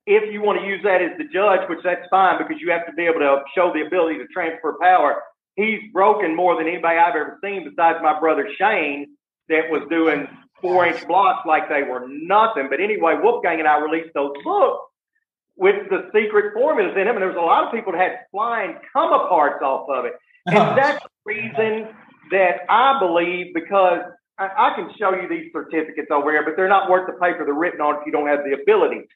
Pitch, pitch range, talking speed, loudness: 180 Hz, 160-215 Hz, 220 wpm, -19 LUFS